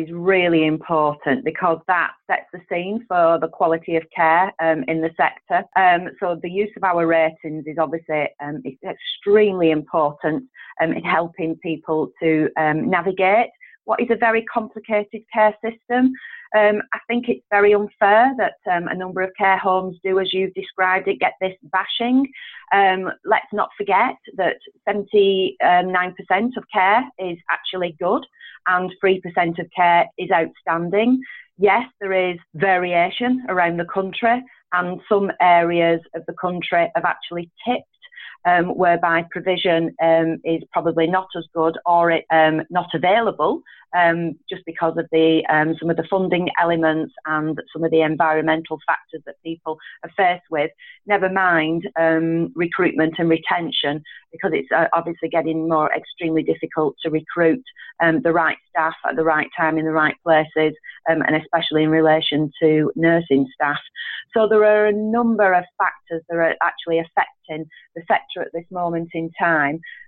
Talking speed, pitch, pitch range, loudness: 160 wpm, 175 Hz, 160-195 Hz, -19 LUFS